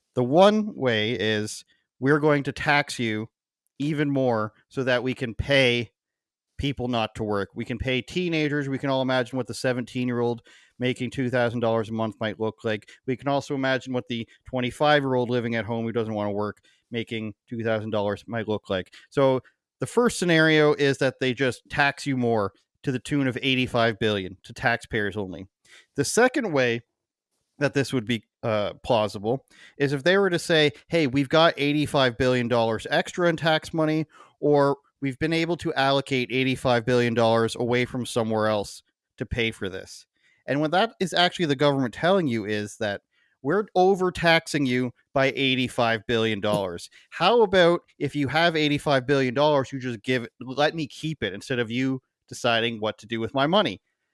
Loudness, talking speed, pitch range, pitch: -24 LUFS, 175 wpm, 115-145 Hz, 130 Hz